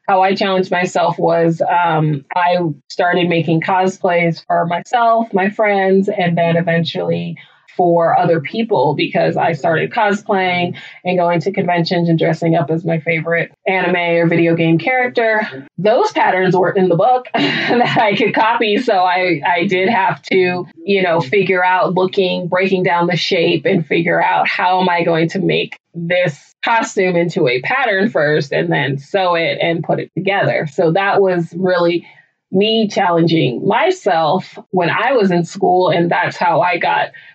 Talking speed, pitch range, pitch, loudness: 165 wpm, 170-195 Hz, 180 Hz, -15 LUFS